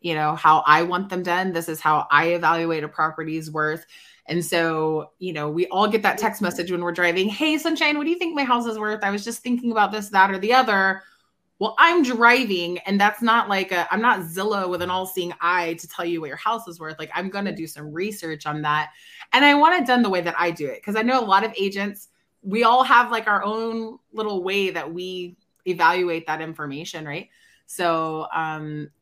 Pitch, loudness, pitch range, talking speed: 185 Hz, -21 LUFS, 165-215 Hz, 240 wpm